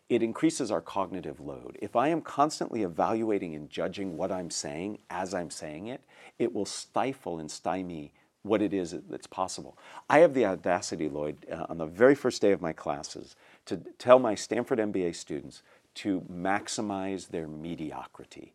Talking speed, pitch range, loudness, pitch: 170 wpm, 80-110 Hz, -30 LUFS, 95 Hz